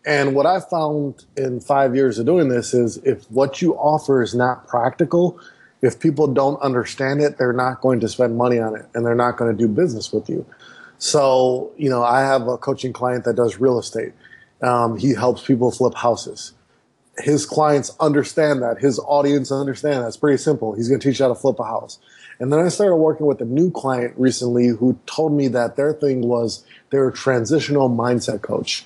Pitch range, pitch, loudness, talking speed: 120-145 Hz, 130 Hz, -19 LUFS, 210 wpm